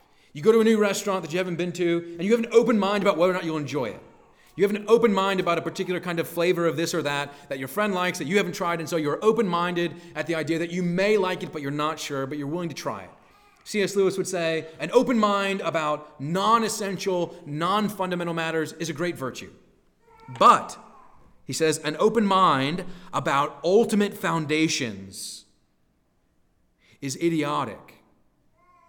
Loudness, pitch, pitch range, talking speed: -24 LUFS, 175 Hz, 155-200 Hz, 205 wpm